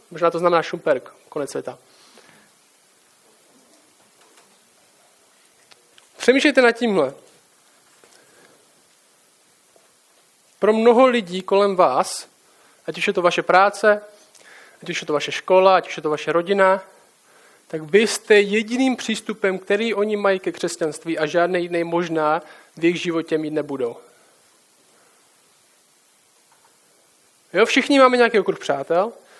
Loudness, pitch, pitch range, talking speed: -19 LUFS, 190 Hz, 170-225 Hz, 115 wpm